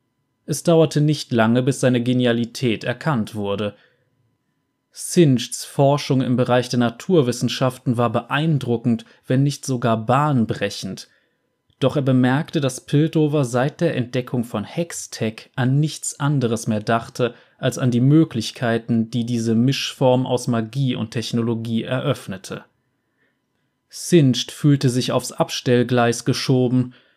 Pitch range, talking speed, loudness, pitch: 120-140 Hz, 120 wpm, -20 LUFS, 125 Hz